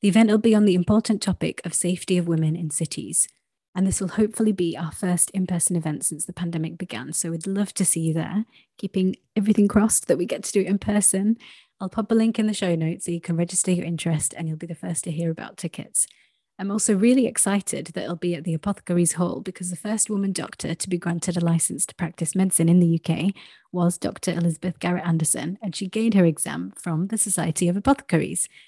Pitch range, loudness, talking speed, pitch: 170-205 Hz, -23 LUFS, 230 wpm, 180 Hz